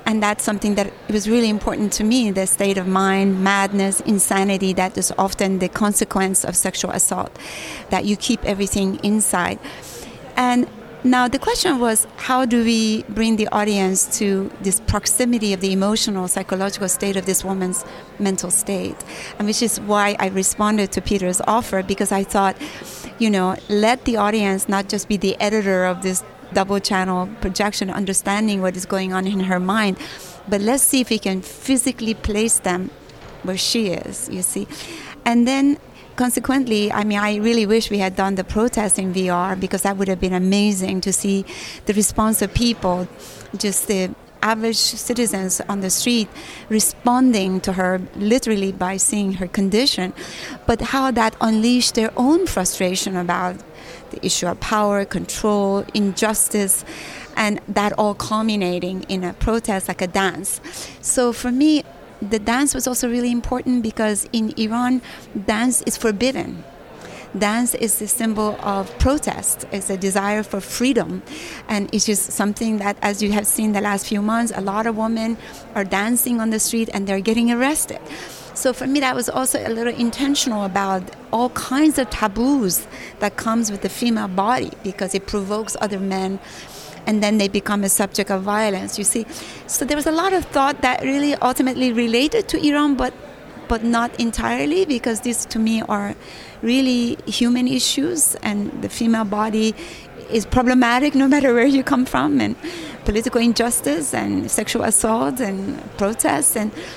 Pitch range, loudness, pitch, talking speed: 195-240 Hz, -19 LUFS, 215 Hz, 170 wpm